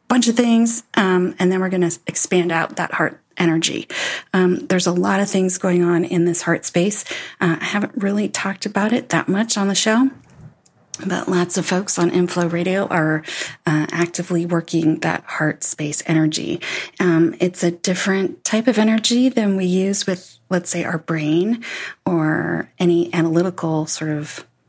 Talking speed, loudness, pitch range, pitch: 175 wpm, -19 LUFS, 170-200 Hz, 180 Hz